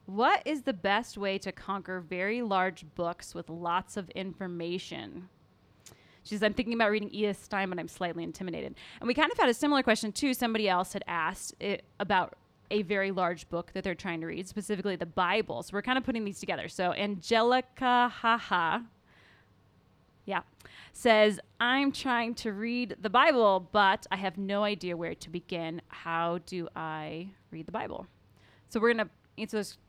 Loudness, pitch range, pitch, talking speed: -30 LUFS, 175-225 Hz, 200 Hz, 185 wpm